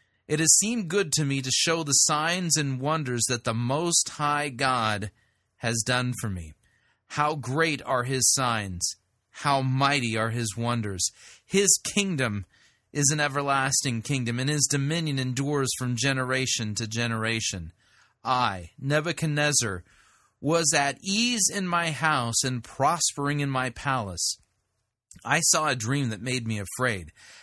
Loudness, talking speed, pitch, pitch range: -25 LUFS, 145 wpm, 130 Hz, 115-150 Hz